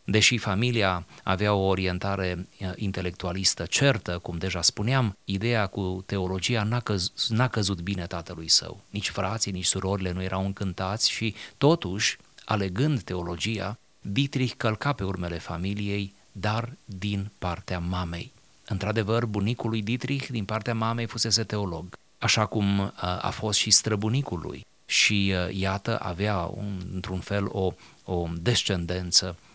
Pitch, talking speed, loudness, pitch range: 100 Hz, 130 wpm, -26 LUFS, 90-110 Hz